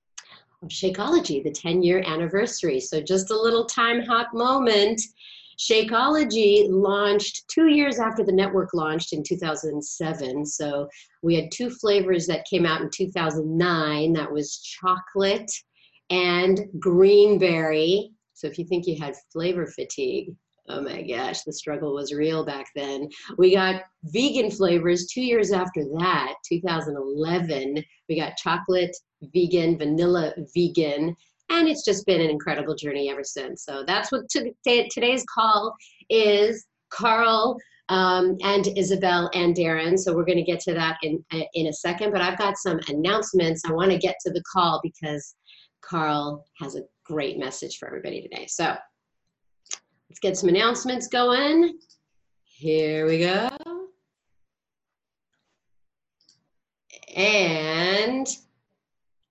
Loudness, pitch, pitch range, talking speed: -23 LUFS, 180 Hz, 160-210 Hz, 145 wpm